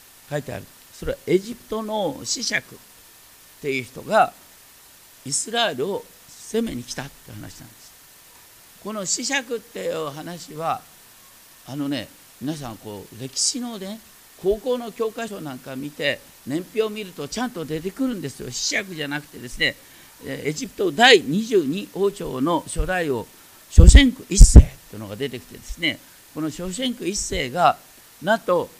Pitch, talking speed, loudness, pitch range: 180 Hz, 275 characters per minute, -22 LUFS, 140-230 Hz